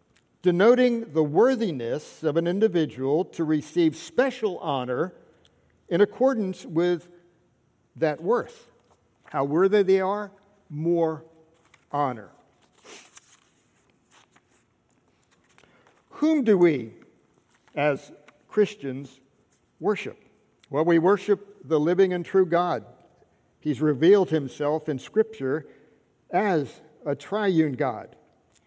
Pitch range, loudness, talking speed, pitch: 155-205 Hz, -24 LUFS, 90 wpm, 170 Hz